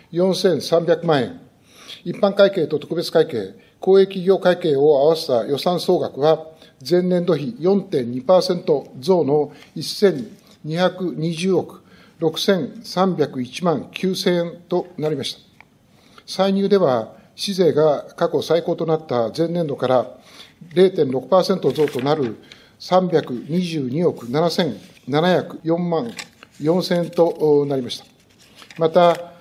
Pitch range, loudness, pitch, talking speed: 155-185 Hz, -19 LUFS, 170 Hz, 155 characters per minute